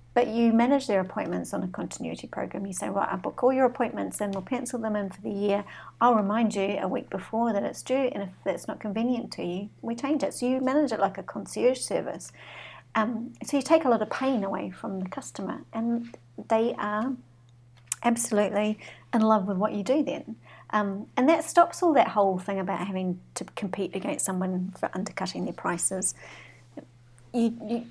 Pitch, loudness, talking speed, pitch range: 215 Hz, -28 LUFS, 205 wpm, 195-245 Hz